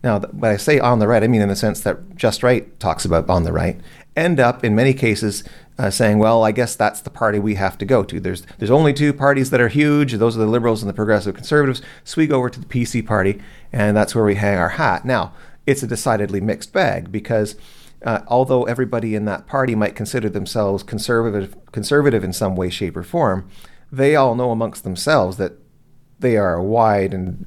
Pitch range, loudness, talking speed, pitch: 100-125 Hz, -18 LUFS, 225 wpm, 110 Hz